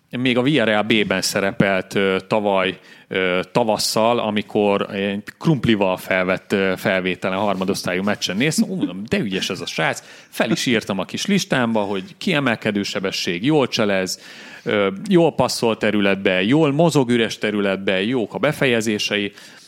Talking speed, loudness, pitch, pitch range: 130 wpm, -19 LUFS, 105 Hz, 95-120 Hz